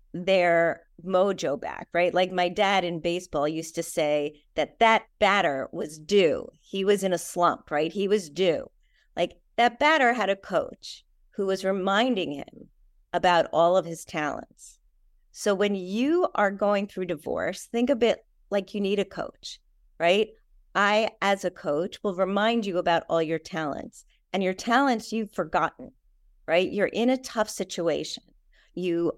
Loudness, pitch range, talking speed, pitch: -26 LUFS, 175-210 Hz, 165 wpm, 190 Hz